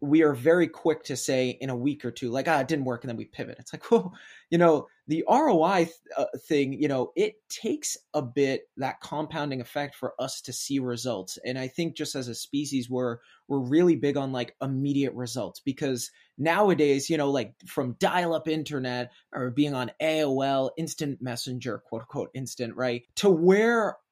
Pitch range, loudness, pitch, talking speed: 125-160 Hz, -27 LUFS, 140 Hz, 200 wpm